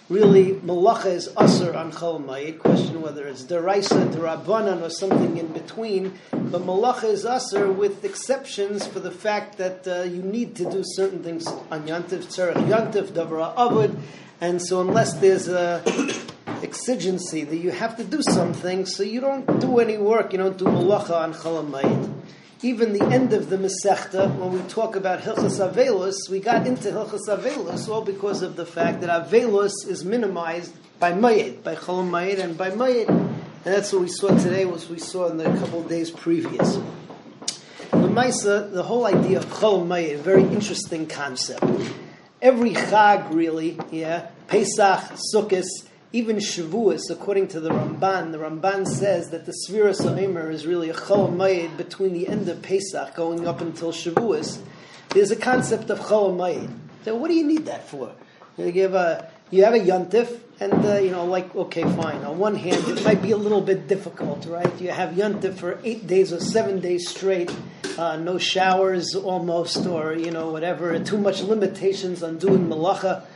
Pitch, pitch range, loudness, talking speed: 190 Hz, 170-205 Hz, -22 LUFS, 175 wpm